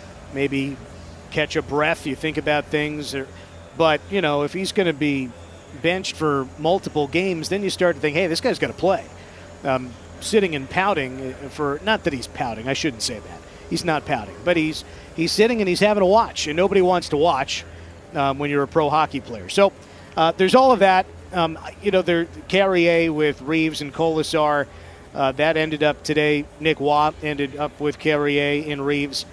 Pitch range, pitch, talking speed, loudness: 135-170 Hz, 150 Hz, 200 wpm, -21 LUFS